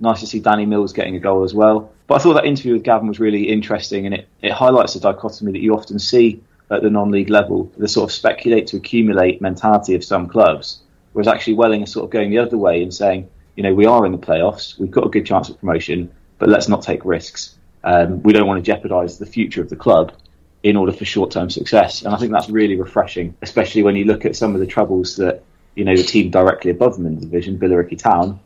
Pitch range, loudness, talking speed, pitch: 95-110 Hz, -16 LUFS, 255 wpm, 105 Hz